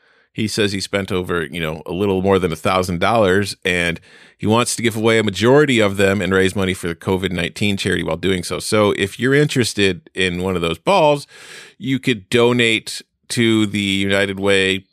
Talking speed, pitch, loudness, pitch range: 195 wpm, 100 Hz, -17 LUFS, 95-110 Hz